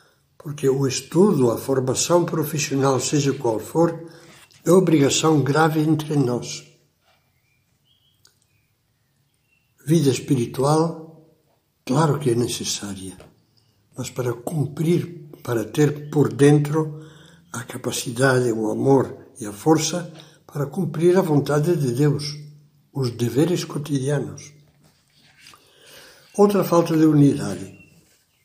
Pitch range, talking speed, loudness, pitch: 130-160 Hz, 100 wpm, -20 LUFS, 145 Hz